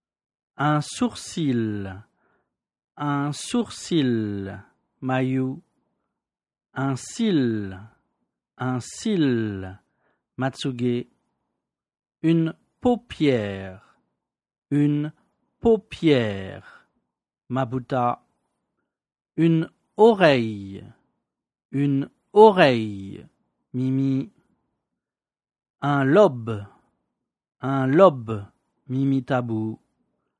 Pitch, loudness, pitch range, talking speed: 130 Hz, -23 LUFS, 110-150 Hz, 50 wpm